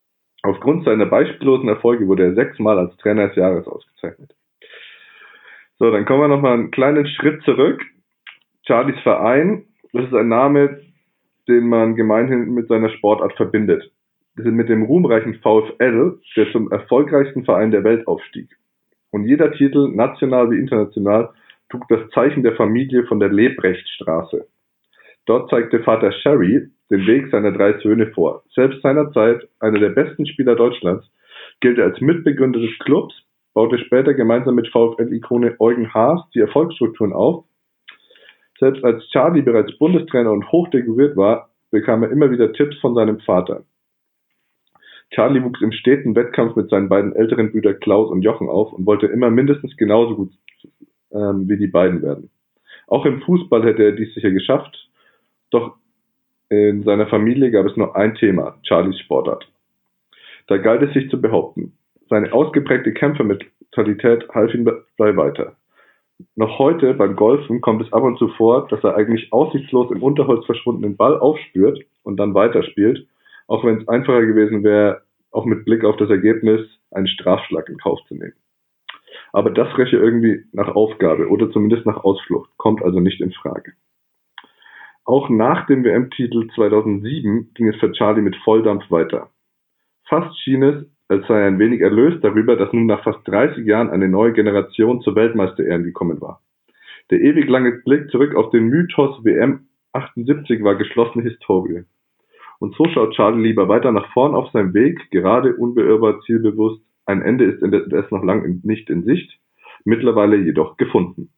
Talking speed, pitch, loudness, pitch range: 160 wpm, 115 Hz, -16 LUFS, 105-135 Hz